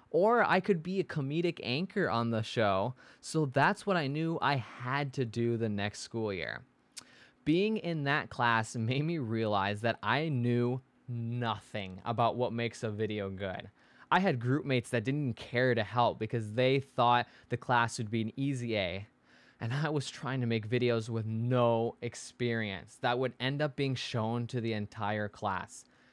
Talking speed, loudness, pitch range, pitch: 180 wpm, -32 LUFS, 115-140 Hz, 120 Hz